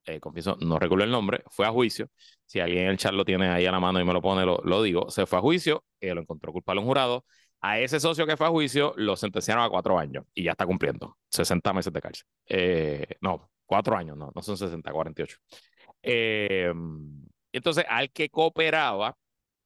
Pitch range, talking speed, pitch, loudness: 90-140 Hz, 220 wpm, 100 Hz, -26 LUFS